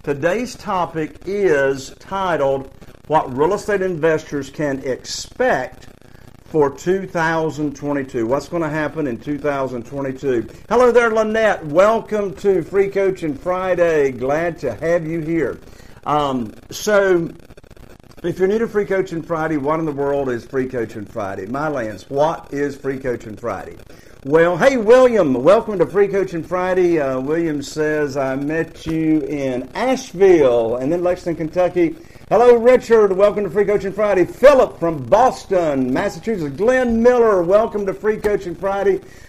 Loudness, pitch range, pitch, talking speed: -18 LUFS, 140-200 Hz, 165 Hz, 140 wpm